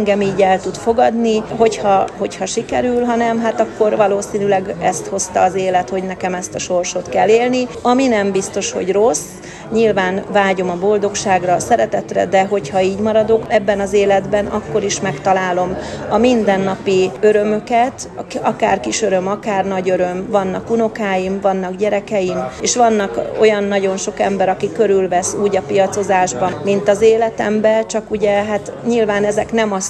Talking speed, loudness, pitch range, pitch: 155 wpm, -16 LUFS, 190-215 Hz, 200 Hz